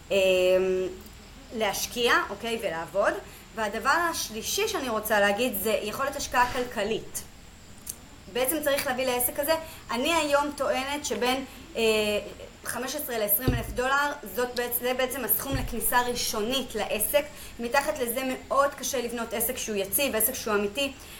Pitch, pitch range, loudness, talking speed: 245 Hz, 215-275 Hz, -27 LUFS, 130 wpm